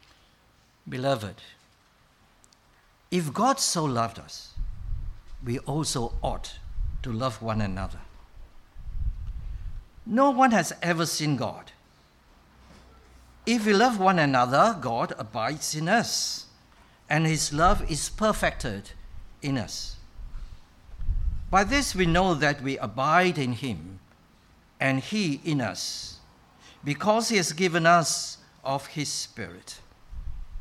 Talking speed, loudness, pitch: 110 wpm, -26 LUFS, 135 Hz